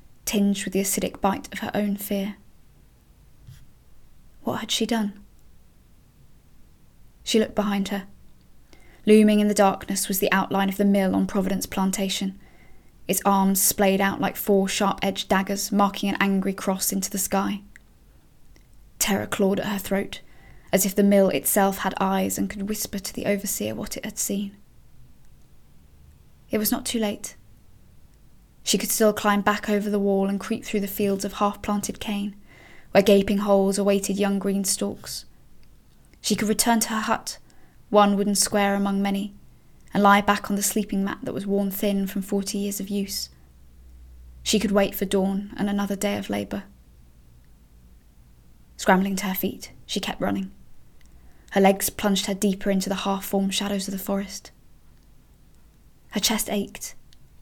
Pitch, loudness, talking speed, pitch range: 200 Hz, -23 LUFS, 165 wpm, 190-205 Hz